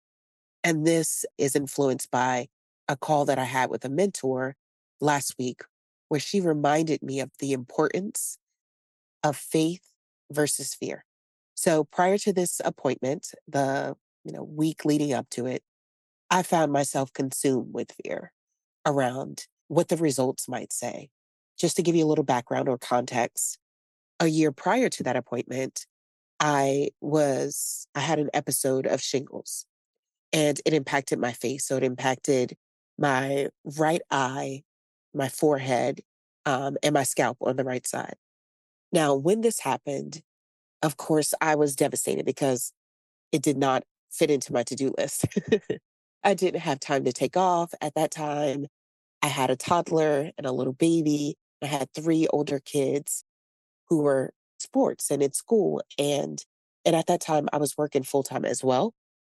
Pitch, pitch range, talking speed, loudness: 145 Hz, 130-155 Hz, 155 wpm, -26 LUFS